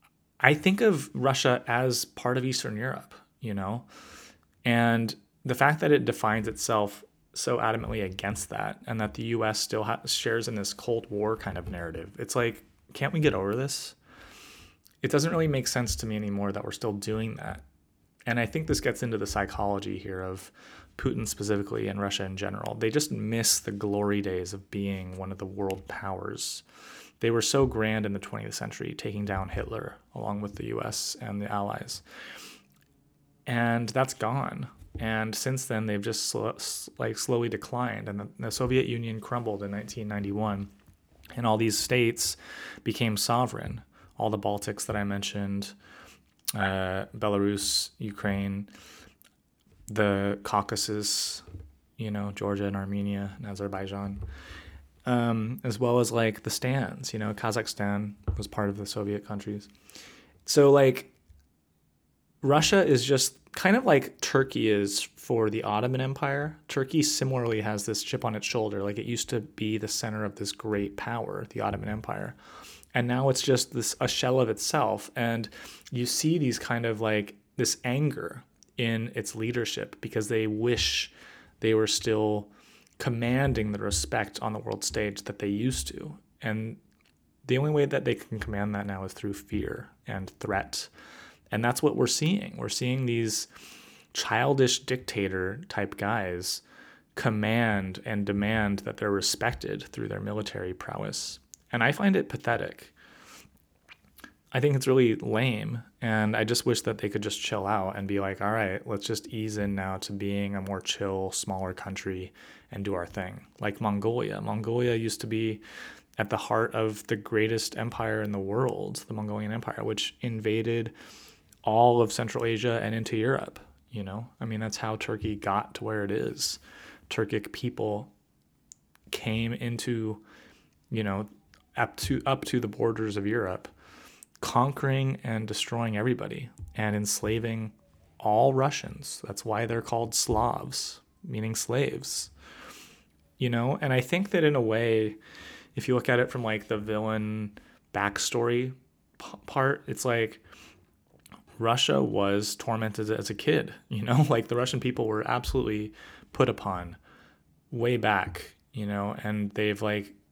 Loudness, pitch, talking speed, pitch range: -29 LUFS, 110 Hz, 160 wpm, 100-120 Hz